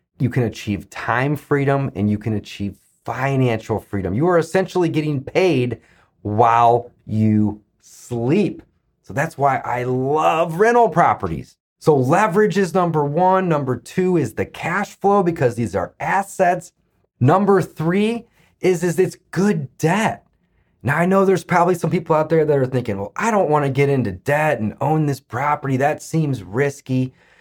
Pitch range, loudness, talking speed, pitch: 120-175 Hz, -19 LUFS, 165 wpm, 145 Hz